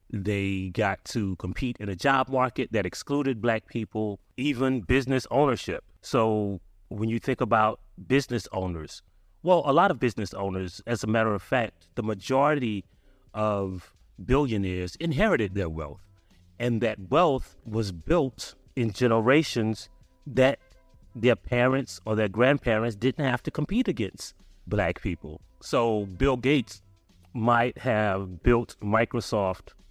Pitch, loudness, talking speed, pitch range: 110 Hz, -26 LUFS, 135 wpm, 95-125 Hz